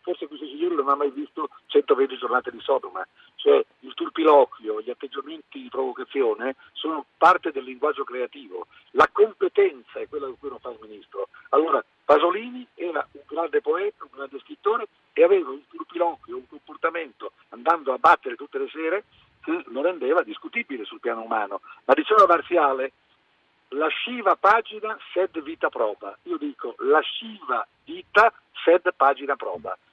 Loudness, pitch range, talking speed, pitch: -23 LUFS, 265-420 Hz, 160 wpm, 370 Hz